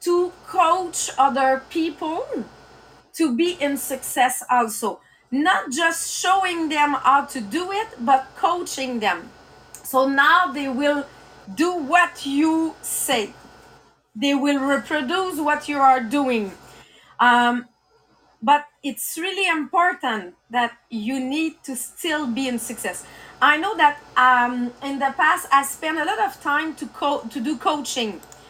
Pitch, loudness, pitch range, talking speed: 285 Hz, -21 LUFS, 255-330 Hz, 140 wpm